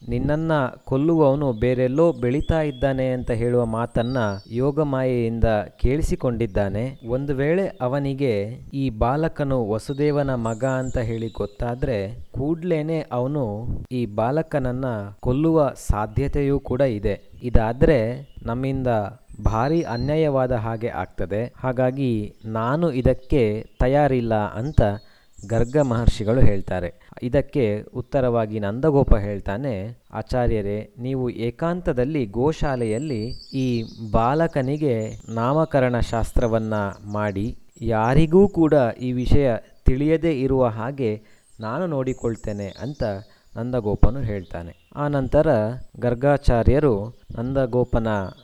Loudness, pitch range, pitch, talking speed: -23 LUFS, 110-140 Hz, 125 Hz, 90 wpm